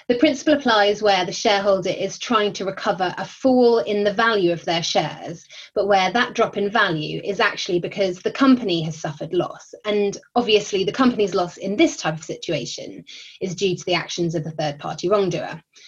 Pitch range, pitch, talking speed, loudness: 175-220 Hz, 195 Hz, 195 wpm, -21 LUFS